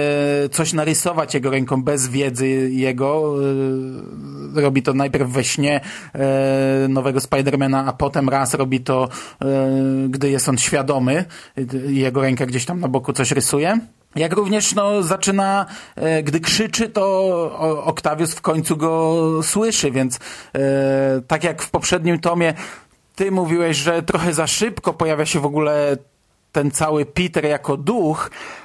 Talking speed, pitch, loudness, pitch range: 135 wpm, 145 Hz, -19 LUFS, 135-170 Hz